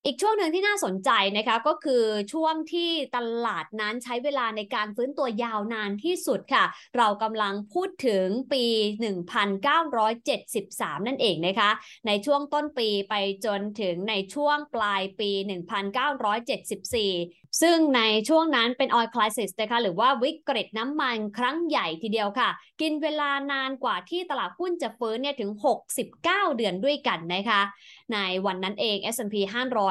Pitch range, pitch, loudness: 205-280 Hz, 230 Hz, -26 LUFS